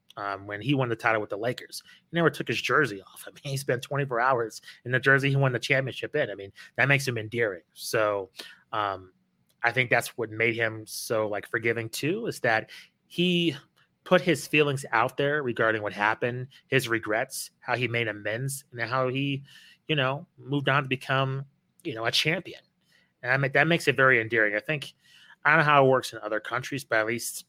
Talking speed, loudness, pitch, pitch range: 210 wpm, -26 LUFS, 130 Hz, 110-140 Hz